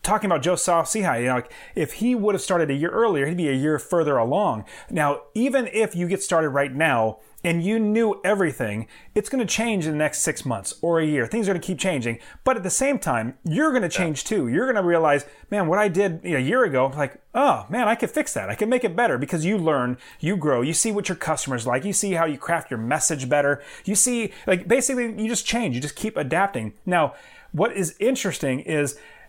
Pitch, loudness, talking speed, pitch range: 175 Hz, -23 LUFS, 240 wpm, 145-215 Hz